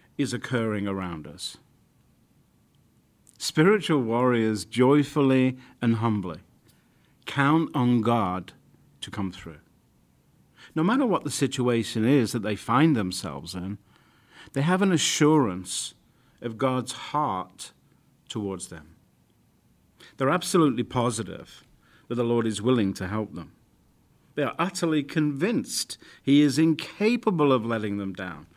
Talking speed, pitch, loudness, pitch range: 120 wpm, 120 Hz, -25 LUFS, 105-145 Hz